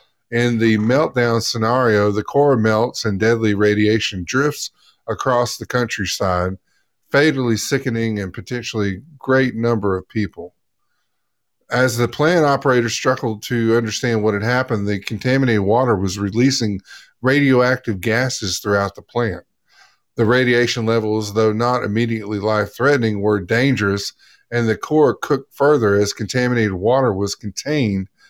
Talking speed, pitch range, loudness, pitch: 130 wpm, 105-125 Hz, -18 LUFS, 115 Hz